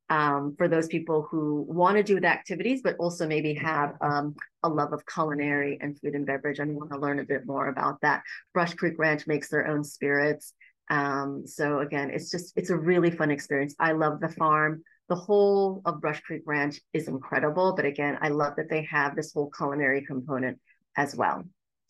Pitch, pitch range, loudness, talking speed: 150 Hz, 145-165 Hz, -27 LUFS, 205 wpm